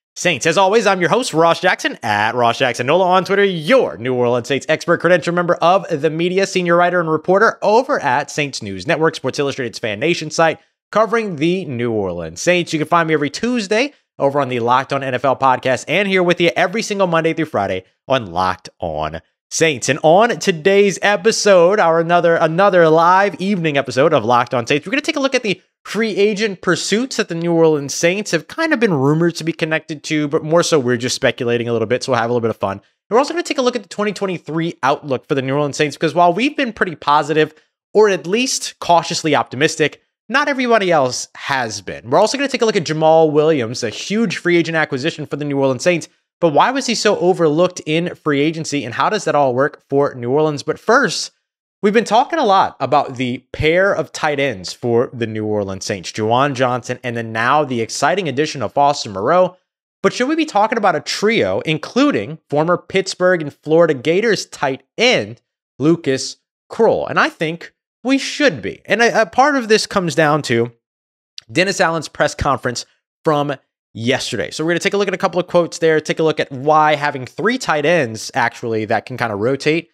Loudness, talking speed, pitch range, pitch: -16 LUFS, 220 wpm, 135-190 Hz, 160 Hz